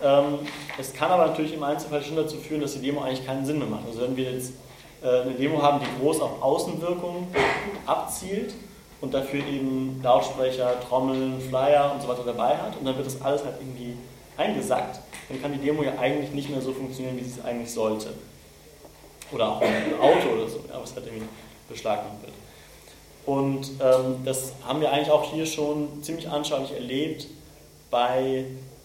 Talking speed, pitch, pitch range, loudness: 180 wpm, 135 Hz, 130-150 Hz, -26 LUFS